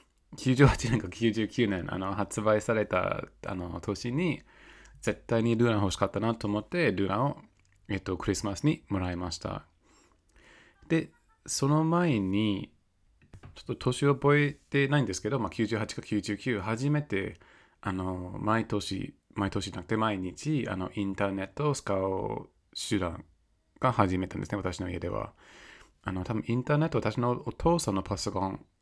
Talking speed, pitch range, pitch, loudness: 290 characters per minute, 95-130 Hz, 105 Hz, -30 LUFS